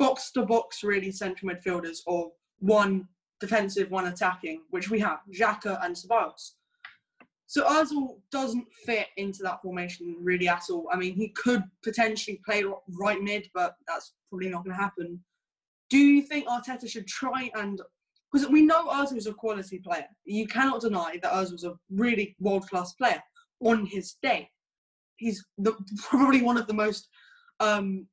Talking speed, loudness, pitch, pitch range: 165 wpm, -28 LUFS, 210 Hz, 185-245 Hz